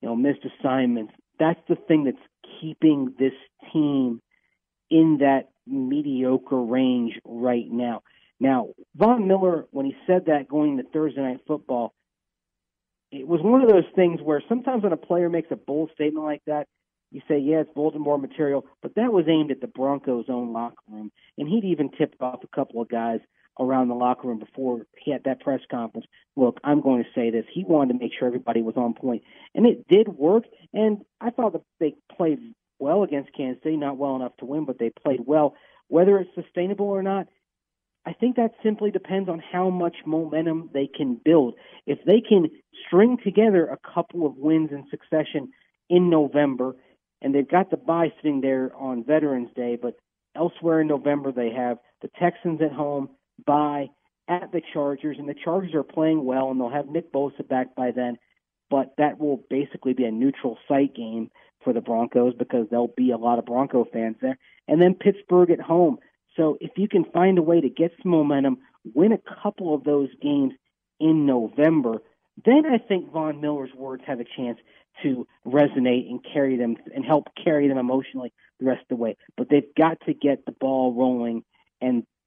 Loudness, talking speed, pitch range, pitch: -23 LUFS, 195 wpm, 130-170 Hz, 145 Hz